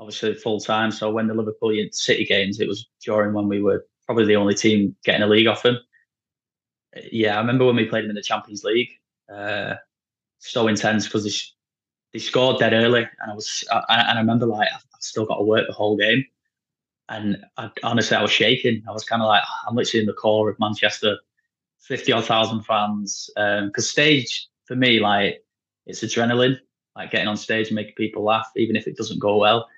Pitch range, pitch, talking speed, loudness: 105-115 Hz, 110 Hz, 210 wpm, -21 LUFS